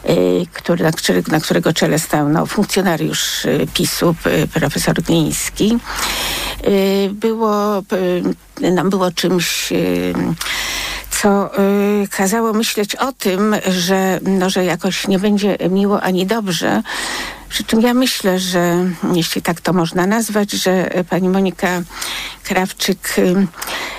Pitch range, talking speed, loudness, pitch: 175-205 Hz, 125 wpm, -16 LUFS, 185 Hz